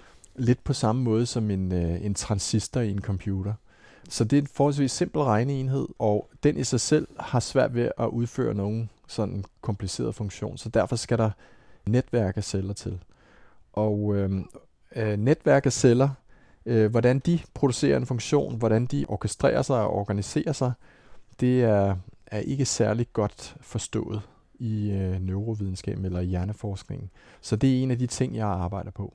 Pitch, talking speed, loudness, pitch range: 110 Hz, 165 wpm, -26 LUFS, 100-125 Hz